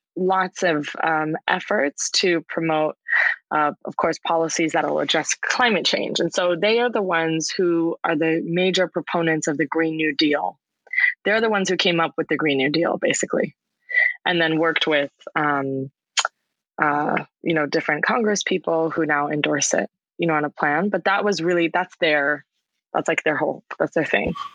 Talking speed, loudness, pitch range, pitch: 185 wpm, -21 LUFS, 155-185 Hz, 165 Hz